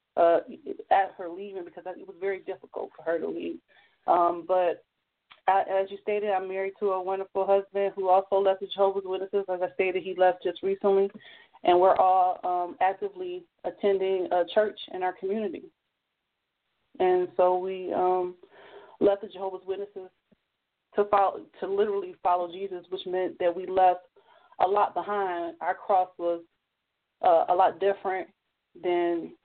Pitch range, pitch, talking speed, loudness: 180-200 Hz, 190 Hz, 160 wpm, -27 LUFS